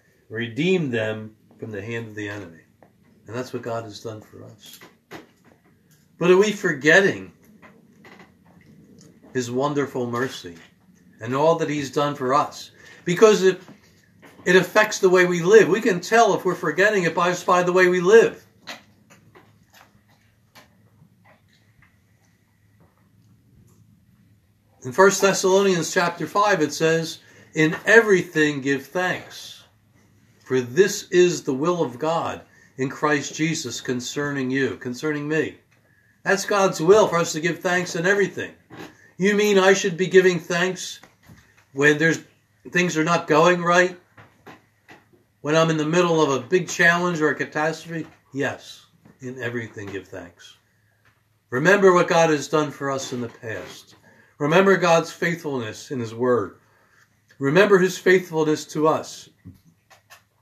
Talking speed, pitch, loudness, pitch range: 135 wpm, 150 Hz, -20 LUFS, 115-180 Hz